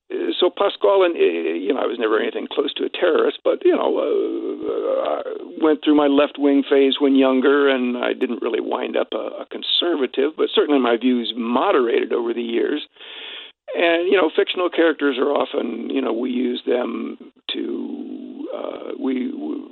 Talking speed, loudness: 185 wpm, -20 LUFS